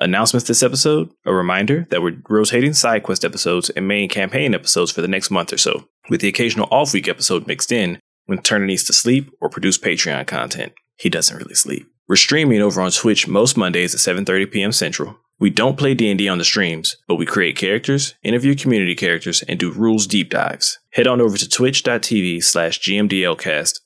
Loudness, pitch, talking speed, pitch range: -16 LUFS, 105 Hz, 195 wpm, 95-125 Hz